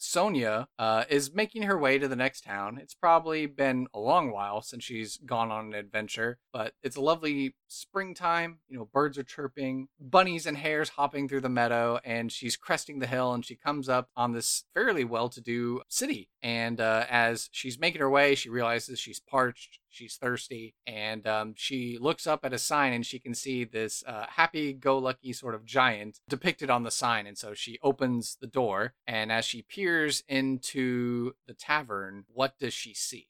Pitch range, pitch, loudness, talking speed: 115-140 Hz, 125 Hz, -30 LUFS, 195 wpm